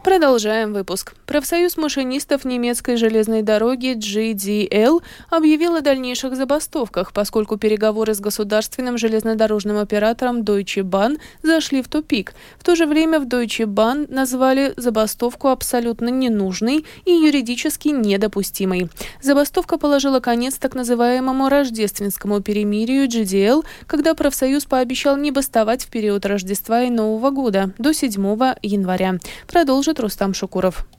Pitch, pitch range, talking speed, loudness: 245 Hz, 215-280 Hz, 120 wpm, -18 LUFS